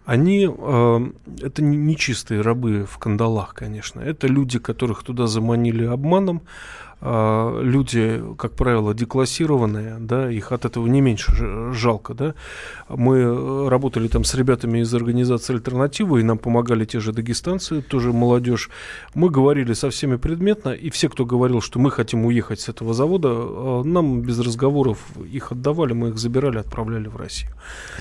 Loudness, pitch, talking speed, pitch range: -20 LUFS, 120 Hz, 150 wpm, 115-135 Hz